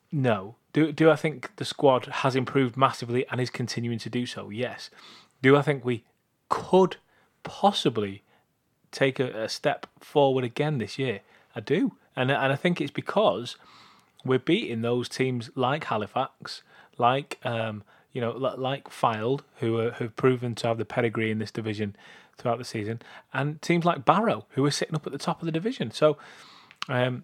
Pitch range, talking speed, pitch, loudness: 120-150 Hz, 175 wpm, 130 Hz, -27 LUFS